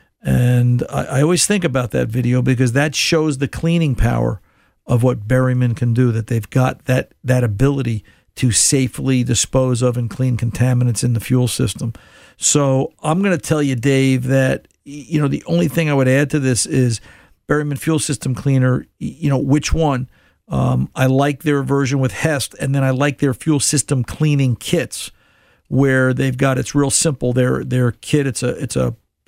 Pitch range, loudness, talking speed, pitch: 125-145 Hz, -17 LUFS, 185 wpm, 130 Hz